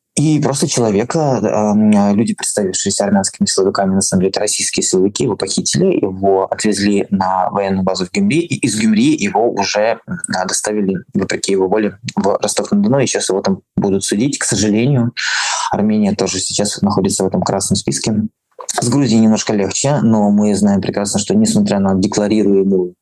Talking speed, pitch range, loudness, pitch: 160 wpm, 95-155 Hz, -15 LUFS, 105 Hz